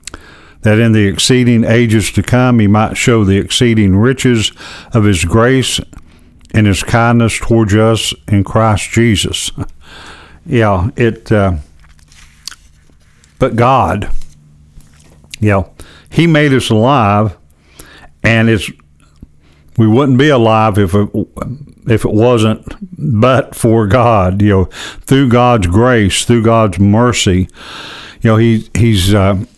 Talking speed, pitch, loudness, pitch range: 125 wpm, 110 Hz, -11 LUFS, 90-115 Hz